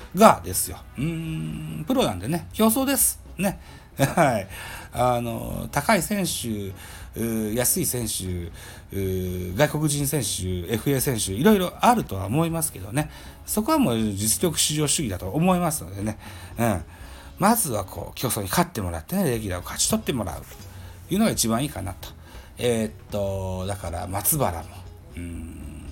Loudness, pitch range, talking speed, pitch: -24 LUFS, 90-150 Hz, 305 characters per minute, 105 Hz